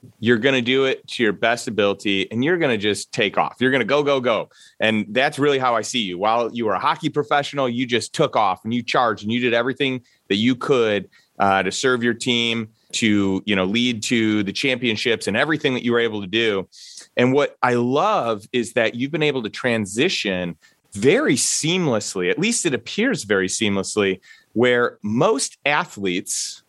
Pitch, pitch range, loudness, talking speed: 120 Hz, 105-130 Hz, -20 LUFS, 205 wpm